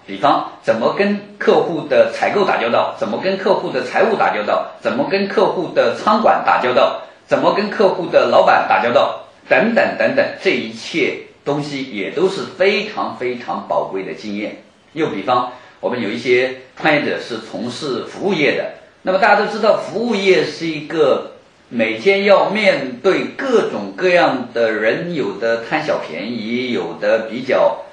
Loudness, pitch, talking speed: -17 LUFS, 190 Hz, 255 characters per minute